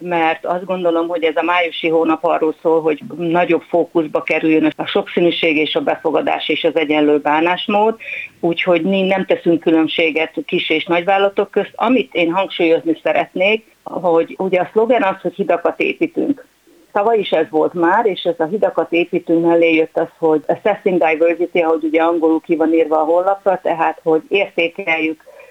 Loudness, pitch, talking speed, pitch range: -16 LUFS, 170 Hz, 170 wpm, 160-190 Hz